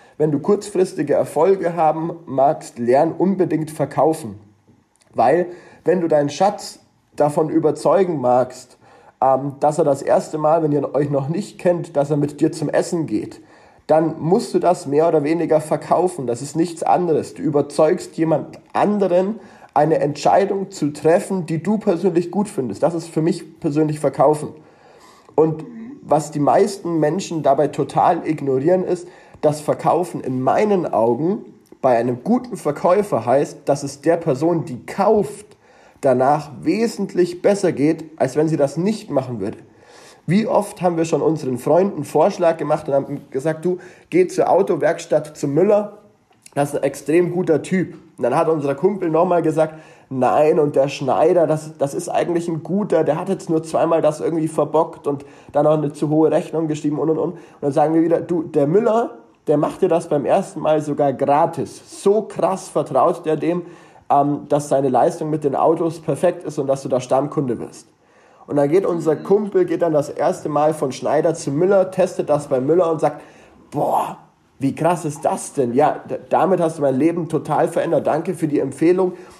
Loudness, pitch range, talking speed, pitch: -19 LUFS, 145-175 Hz, 180 wpm, 160 Hz